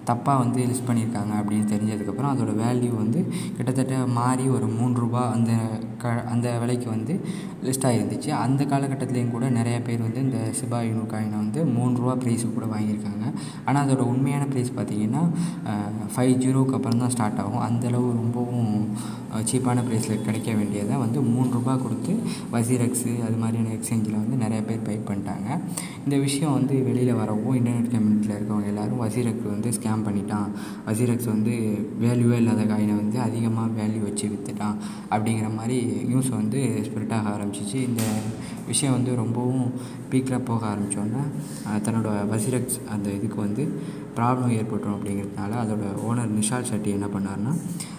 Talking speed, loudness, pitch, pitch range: 145 wpm, -25 LUFS, 115 Hz, 105-125 Hz